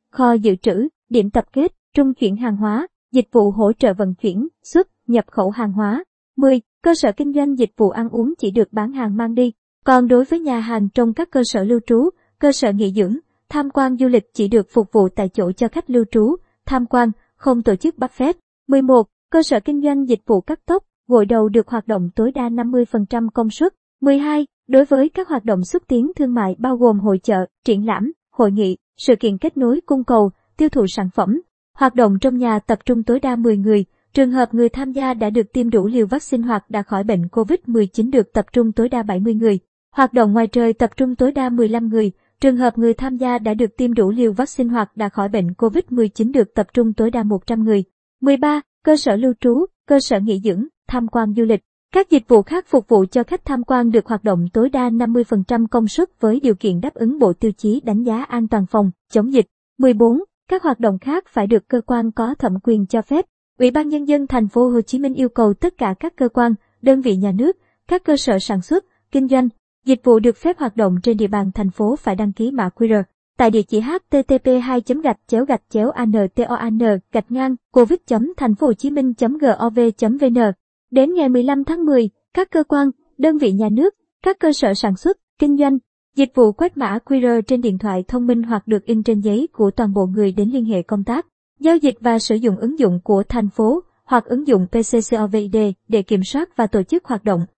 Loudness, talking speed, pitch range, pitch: -17 LUFS, 225 wpm, 220-270 Hz, 235 Hz